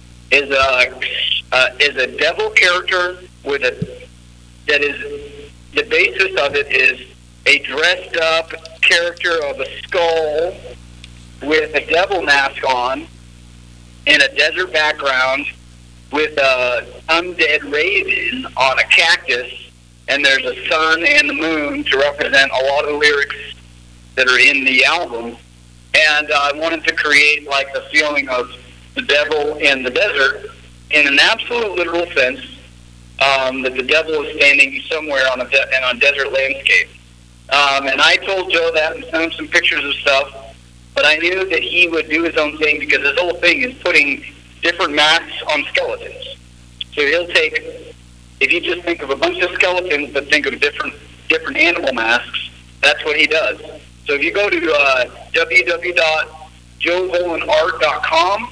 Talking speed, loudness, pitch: 160 wpm, -14 LUFS, 145 Hz